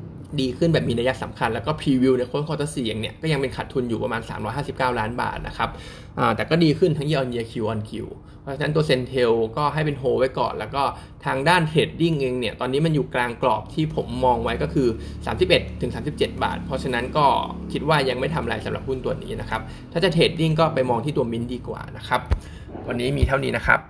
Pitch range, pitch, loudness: 120-155 Hz, 130 Hz, -23 LUFS